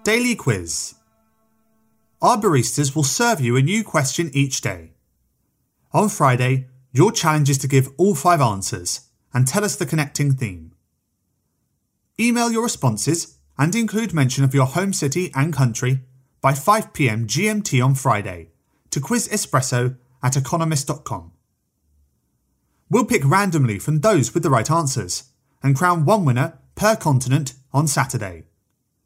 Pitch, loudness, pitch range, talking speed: 135 Hz, -19 LUFS, 120-165 Hz, 135 wpm